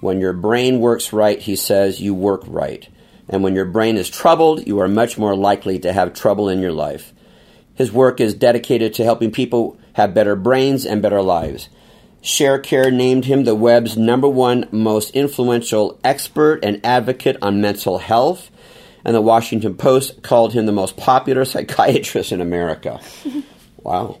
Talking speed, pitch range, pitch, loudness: 170 wpm, 100-130 Hz, 115 Hz, -16 LUFS